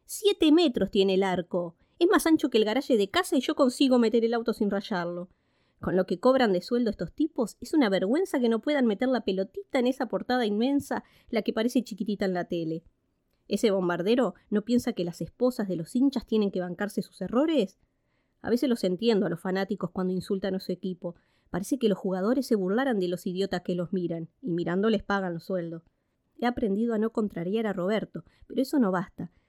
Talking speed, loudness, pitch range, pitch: 210 wpm, -27 LUFS, 185-250 Hz, 210 Hz